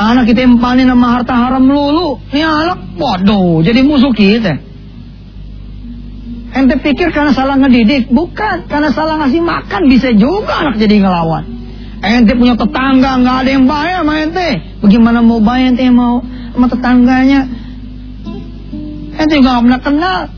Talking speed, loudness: 150 wpm, -10 LUFS